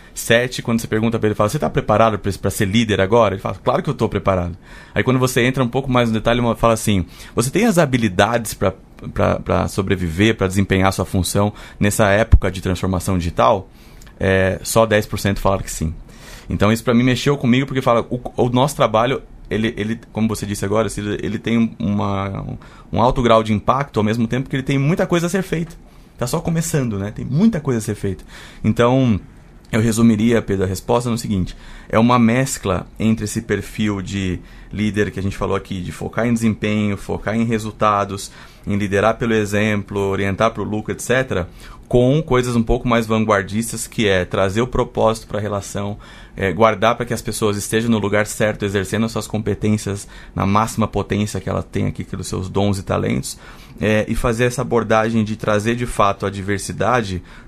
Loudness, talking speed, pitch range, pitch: -18 LUFS, 195 wpm, 100-115 Hz, 110 Hz